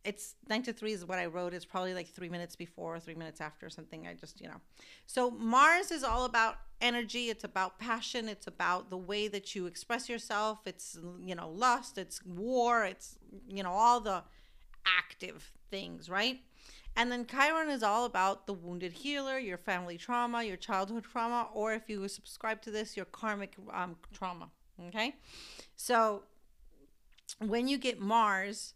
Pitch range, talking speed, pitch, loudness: 185-235 Hz, 175 wpm, 210 Hz, -34 LUFS